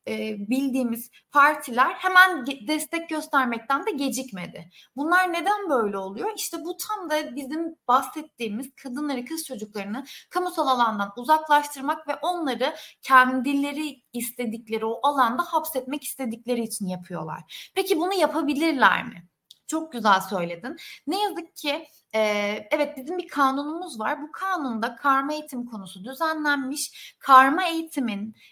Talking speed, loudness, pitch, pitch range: 120 wpm, -24 LUFS, 275 Hz, 240-315 Hz